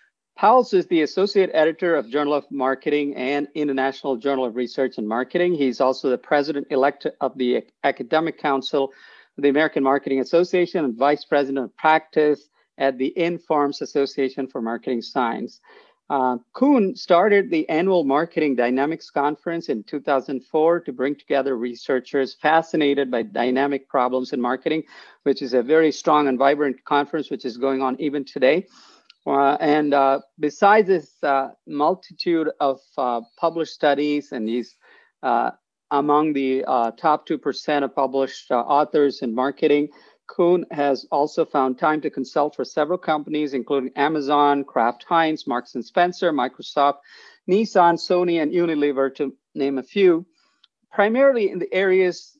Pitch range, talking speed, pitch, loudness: 135-165 Hz, 150 wpm, 145 Hz, -21 LUFS